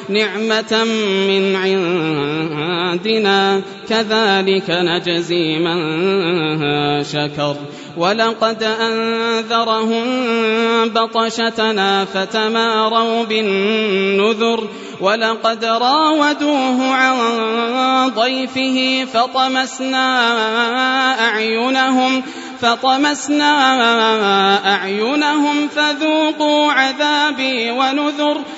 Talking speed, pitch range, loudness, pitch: 50 wpm, 195-260 Hz, -15 LUFS, 225 Hz